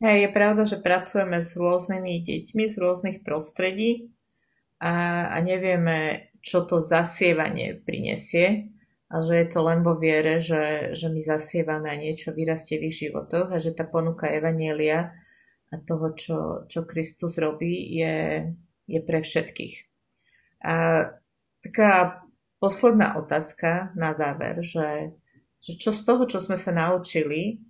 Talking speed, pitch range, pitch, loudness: 140 wpm, 160-185 Hz, 170 Hz, -25 LUFS